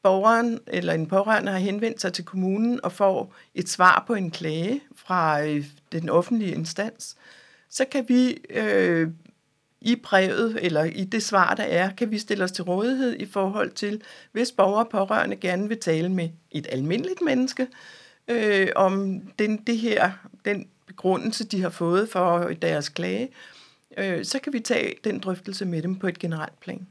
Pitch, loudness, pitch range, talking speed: 195 Hz, -24 LUFS, 180-230 Hz, 175 wpm